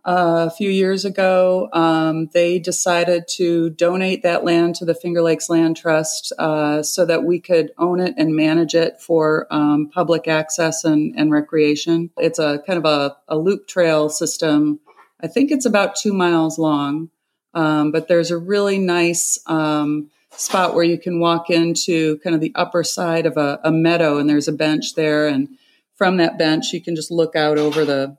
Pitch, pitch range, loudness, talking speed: 165 Hz, 155-175 Hz, -18 LUFS, 190 wpm